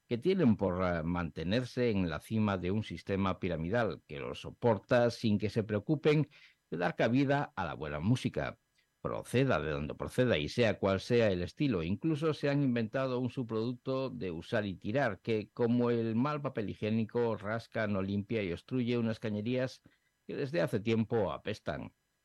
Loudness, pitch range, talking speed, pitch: -33 LUFS, 100-125 Hz, 170 wpm, 115 Hz